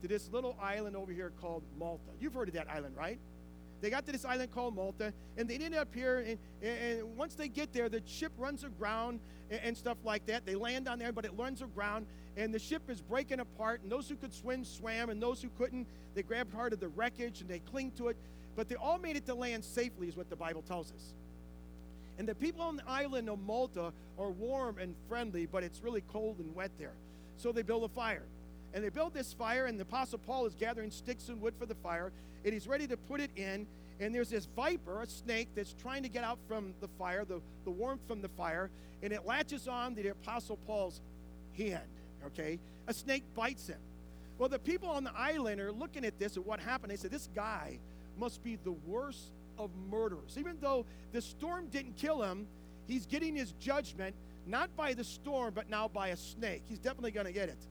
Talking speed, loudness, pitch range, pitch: 230 wpm, -40 LUFS, 185-250 Hz, 225 Hz